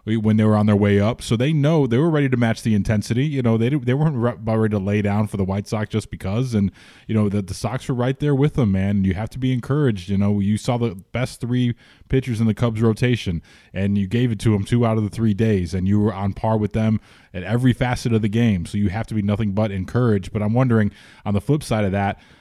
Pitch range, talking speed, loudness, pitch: 100-120 Hz, 275 wpm, -20 LUFS, 110 Hz